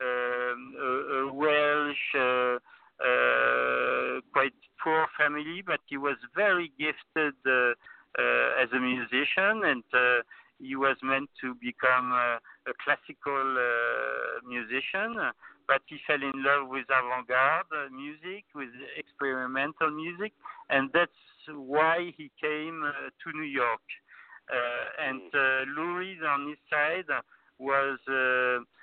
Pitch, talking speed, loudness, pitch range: 135 Hz, 125 wpm, -28 LUFS, 125-150 Hz